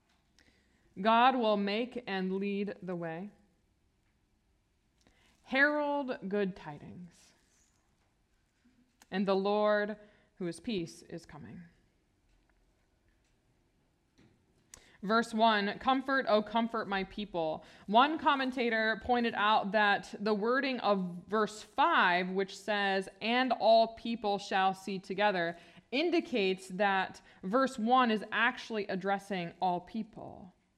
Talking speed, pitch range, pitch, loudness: 100 wpm, 185-230 Hz, 205 Hz, -31 LUFS